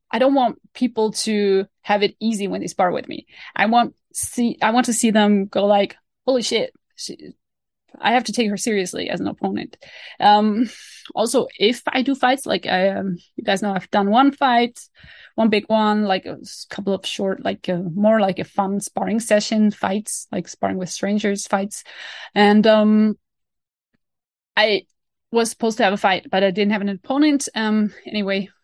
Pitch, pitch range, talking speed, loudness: 215 Hz, 200-235 Hz, 190 wpm, -19 LUFS